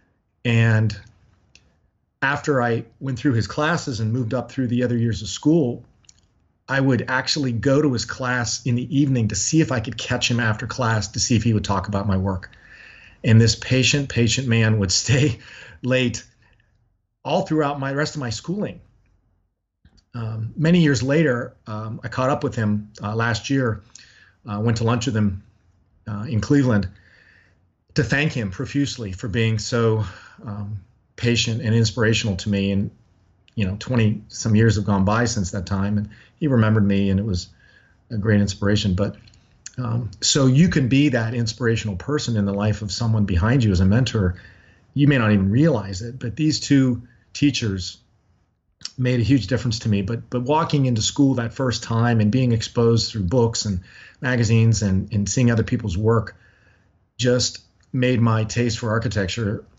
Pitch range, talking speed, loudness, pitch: 105-125 Hz, 180 wpm, -21 LUFS, 115 Hz